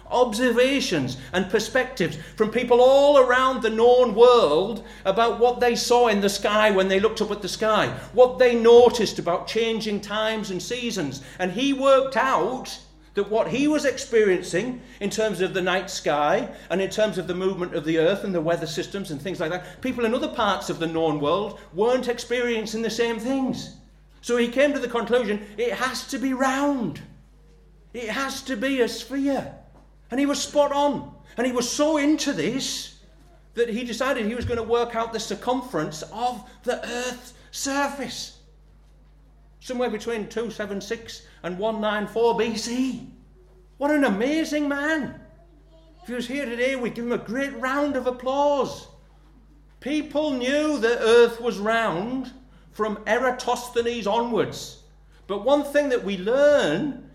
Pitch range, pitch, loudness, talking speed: 210-260 Hz, 235 Hz, -23 LUFS, 165 wpm